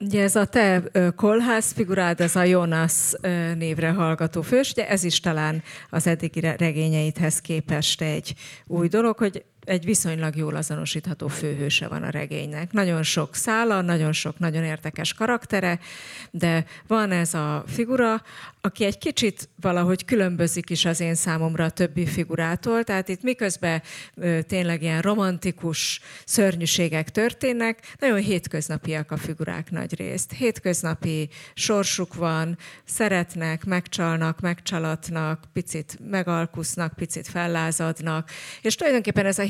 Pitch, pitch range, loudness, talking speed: 170 Hz, 160-195 Hz, -24 LUFS, 130 wpm